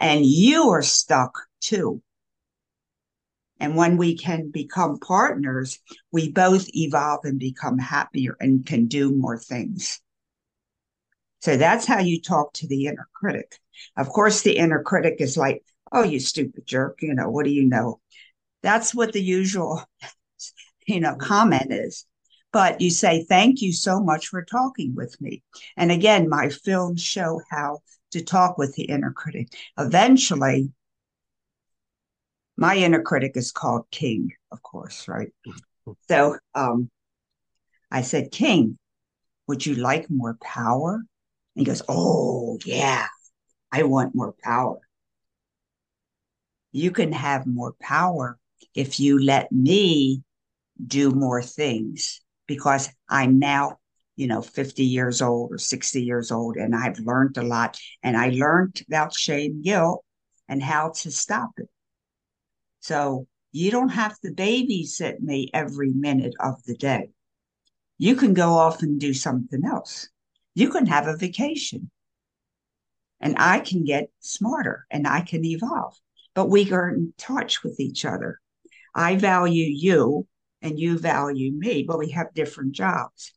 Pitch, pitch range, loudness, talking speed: 150 Hz, 135-180 Hz, -22 LUFS, 145 wpm